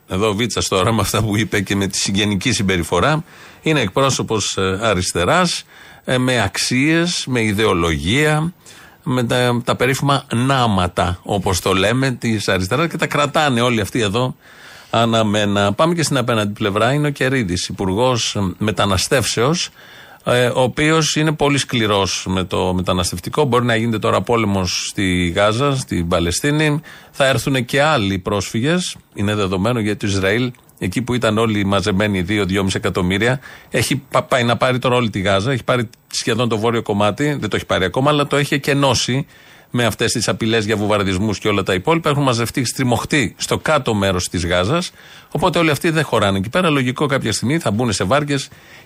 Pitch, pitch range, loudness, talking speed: 115 Hz, 100-140 Hz, -17 LUFS, 165 wpm